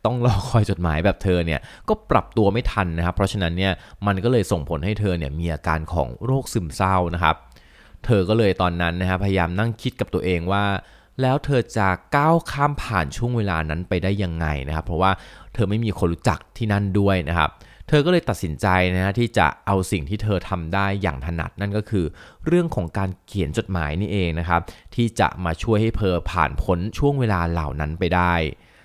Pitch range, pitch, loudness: 85-110 Hz, 95 Hz, -22 LUFS